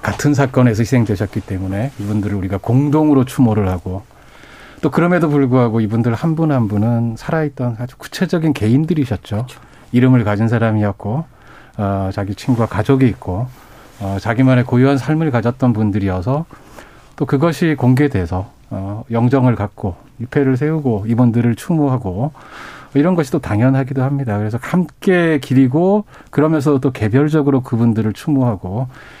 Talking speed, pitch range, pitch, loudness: 350 characters per minute, 110-145 Hz, 125 Hz, -16 LUFS